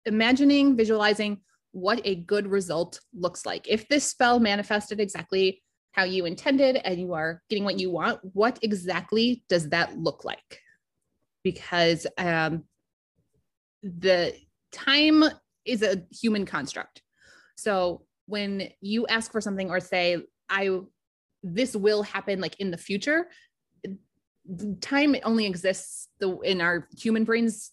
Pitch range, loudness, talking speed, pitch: 185-225 Hz, -26 LUFS, 130 wpm, 200 Hz